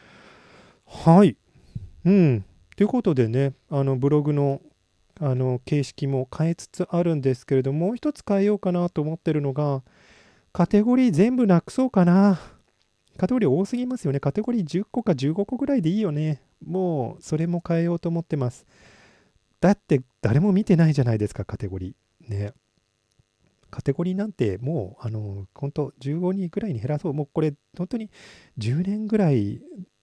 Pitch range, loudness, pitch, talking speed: 130-185 Hz, -23 LUFS, 155 Hz, 325 characters per minute